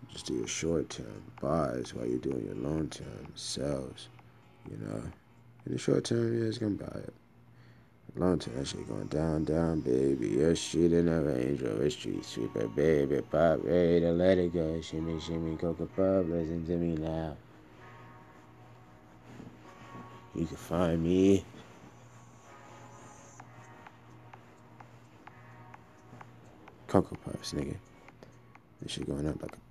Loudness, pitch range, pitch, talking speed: -31 LUFS, 60-85 Hz, 80 Hz, 145 wpm